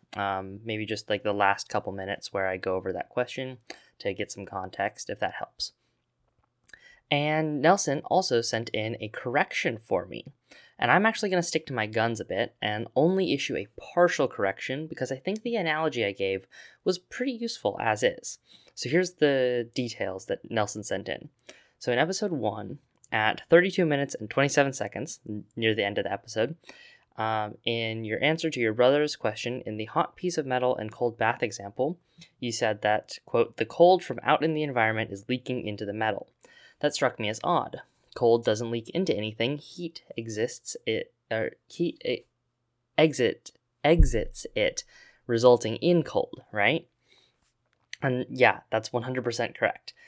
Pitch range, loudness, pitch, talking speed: 110-160 Hz, -28 LUFS, 125 Hz, 175 wpm